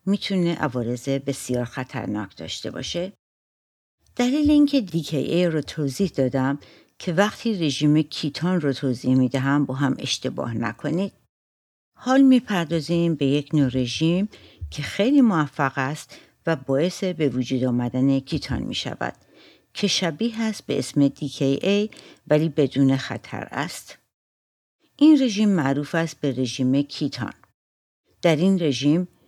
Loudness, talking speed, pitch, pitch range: -23 LUFS, 125 wpm, 145 Hz, 135-180 Hz